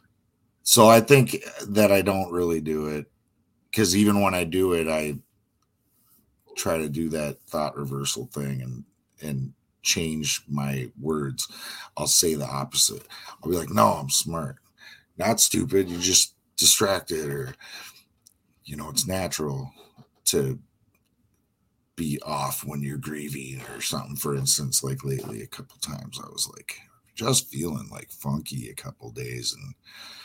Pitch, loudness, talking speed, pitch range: 75 Hz, -24 LUFS, 145 wpm, 70-95 Hz